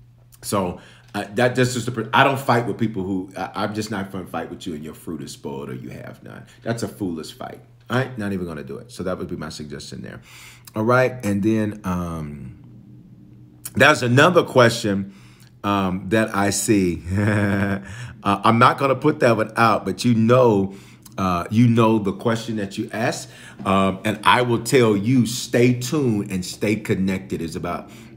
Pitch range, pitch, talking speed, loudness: 95-120 Hz, 105 Hz, 200 wpm, -20 LUFS